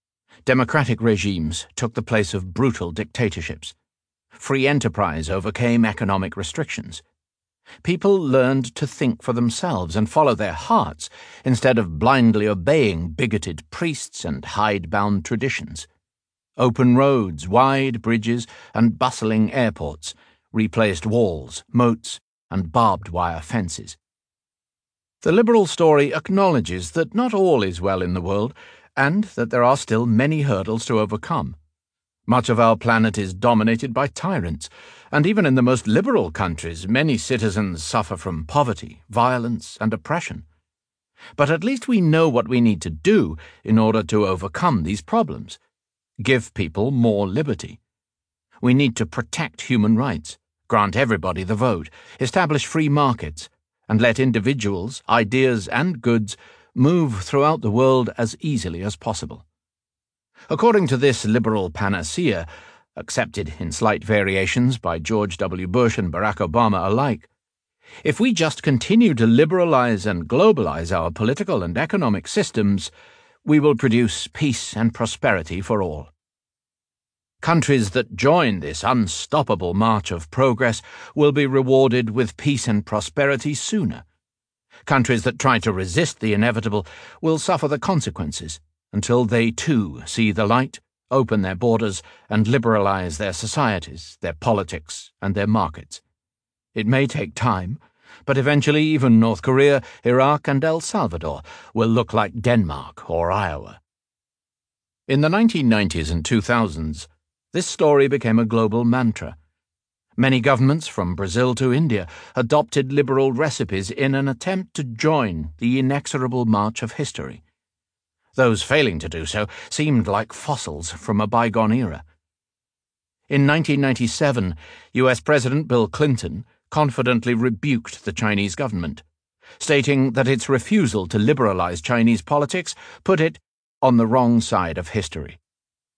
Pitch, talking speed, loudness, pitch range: 115 Hz, 135 wpm, -20 LUFS, 100-135 Hz